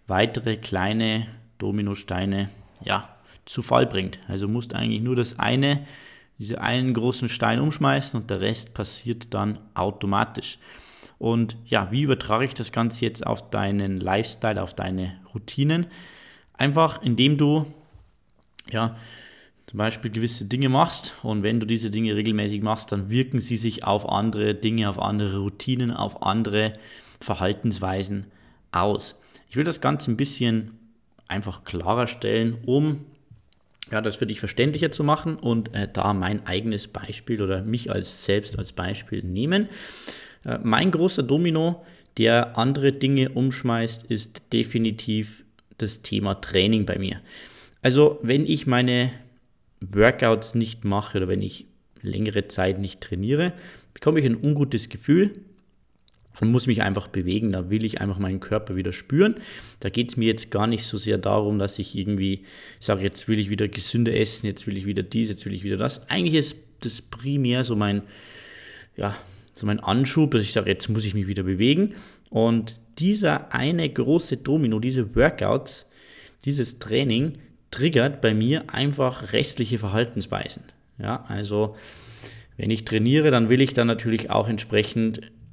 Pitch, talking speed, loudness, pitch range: 115 Hz, 155 wpm, -24 LUFS, 105-125 Hz